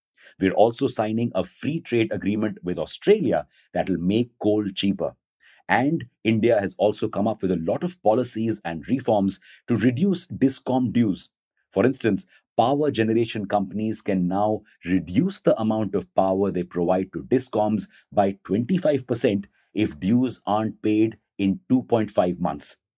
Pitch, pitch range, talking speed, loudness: 110 Hz, 95-120 Hz, 145 wpm, -24 LUFS